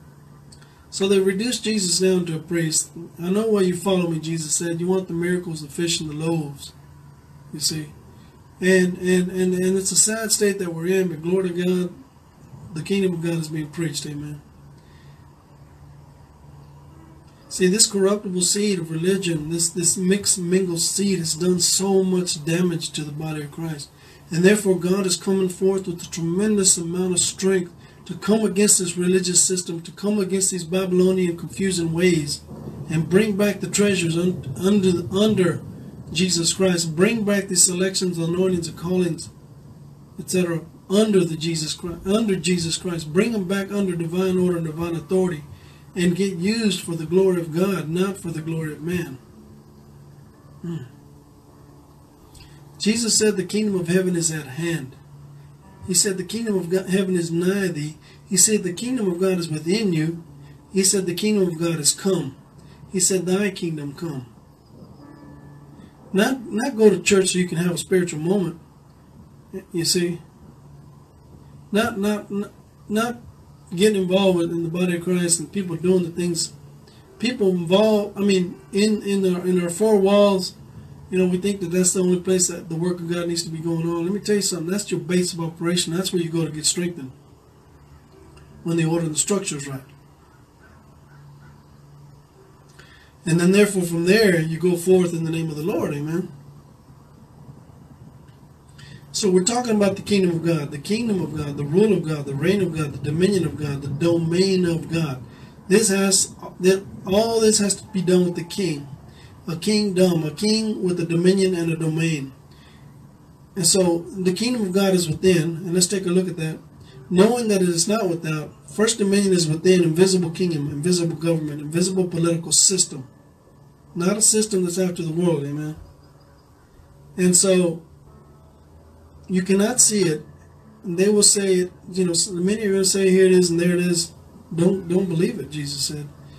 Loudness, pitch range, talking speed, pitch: -21 LUFS, 160-190 Hz, 180 wpm, 175 Hz